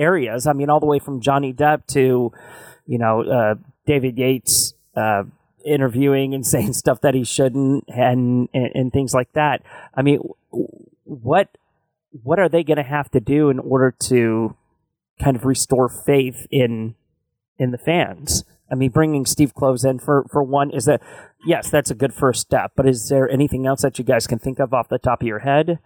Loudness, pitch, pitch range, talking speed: -19 LUFS, 135 Hz, 125-140 Hz, 195 wpm